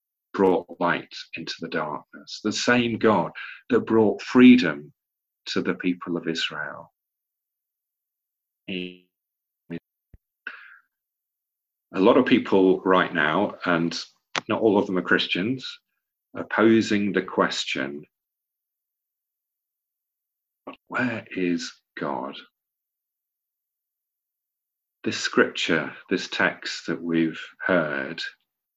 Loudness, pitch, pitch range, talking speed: -23 LUFS, 90 Hz, 85-105 Hz, 90 wpm